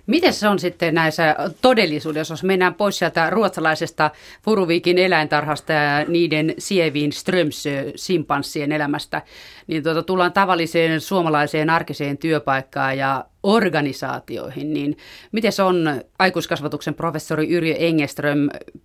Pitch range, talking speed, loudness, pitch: 150-180 Hz, 115 wpm, -20 LUFS, 160 Hz